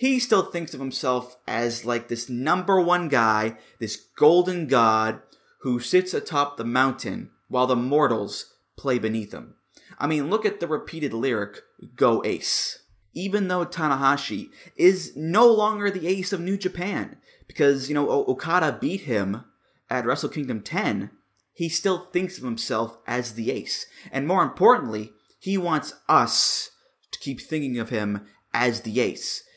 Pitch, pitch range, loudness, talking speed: 135 Hz, 120-180 Hz, -24 LUFS, 155 wpm